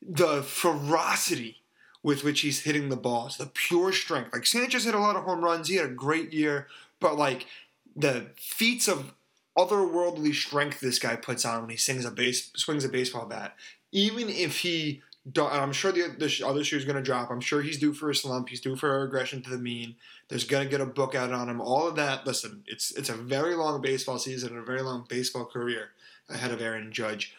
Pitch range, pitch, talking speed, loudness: 125-155 Hz, 140 Hz, 225 wpm, -28 LUFS